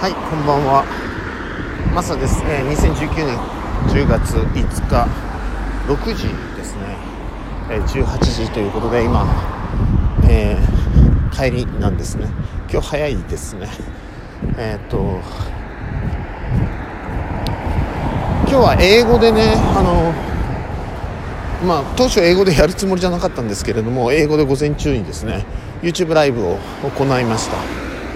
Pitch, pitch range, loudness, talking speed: 110 Hz, 95-145 Hz, -17 LUFS, 230 characters per minute